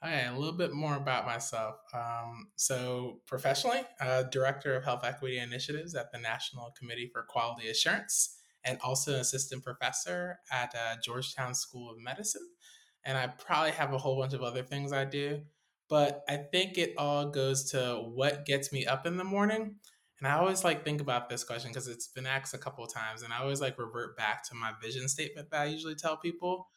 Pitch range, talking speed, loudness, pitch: 120-150 Hz, 205 wpm, -34 LUFS, 135 Hz